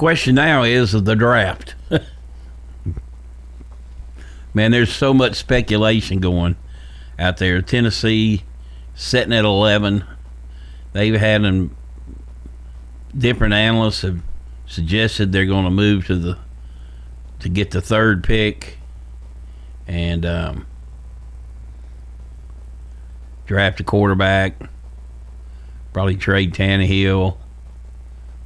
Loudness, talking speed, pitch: -17 LUFS, 95 wpm, 80 Hz